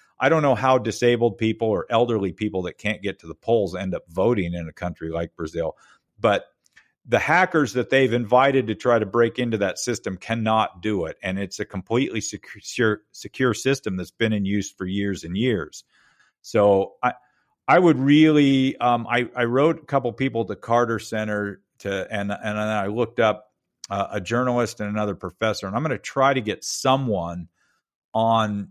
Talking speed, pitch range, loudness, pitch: 190 wpm, 100-120 Hz, -22 LUFS, 110 Hz